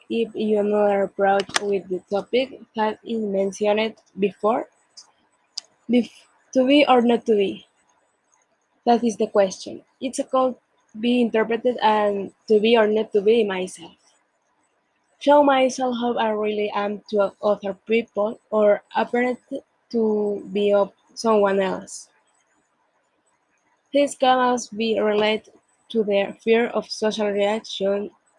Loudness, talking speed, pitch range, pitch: -21 LUFS, 130 wpm, 205-240 Hz, 215 Hz